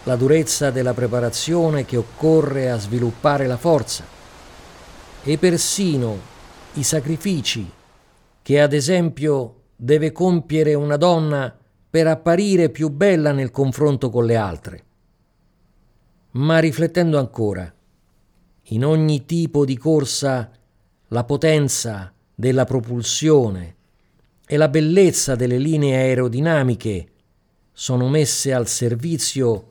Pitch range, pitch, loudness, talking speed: 120-155 Hz, 135 Hz, -19 LUFS, 105 wpm